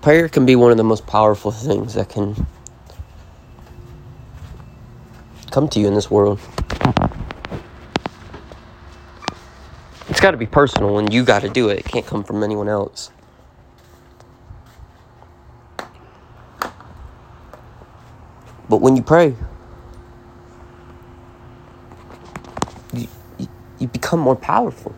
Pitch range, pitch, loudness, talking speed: 100-125 Hz, 110 Hz, -17 LUFS, 105 wpm